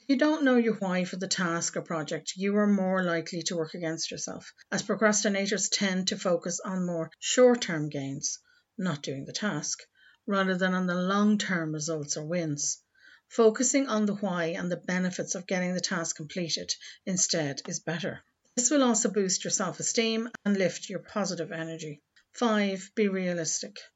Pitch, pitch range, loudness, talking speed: 185 Hz, 170-210 Hz, -28 LUFS, 180 wpm